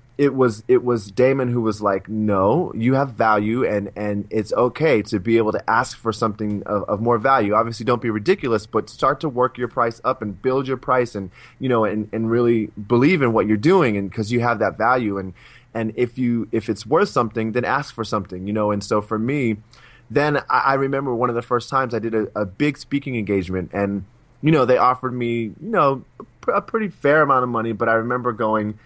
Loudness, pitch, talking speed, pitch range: -20 LUFS, 115 Hz, 235 wpm, 105-125 Hz